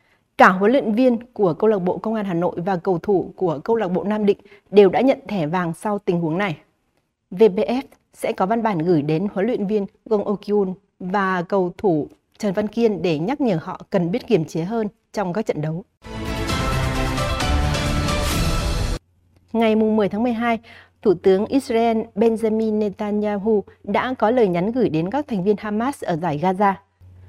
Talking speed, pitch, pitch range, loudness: 180 wpm, 205 Hz, 170-220 Hz, -21 LUFS